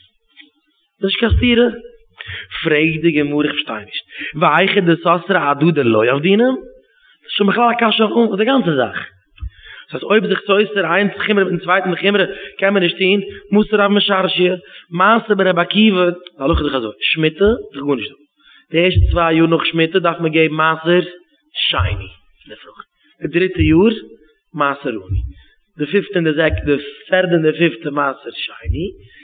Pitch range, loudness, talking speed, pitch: 155-205 Hz, -15 LUFS, 160 wpm, 180 Hz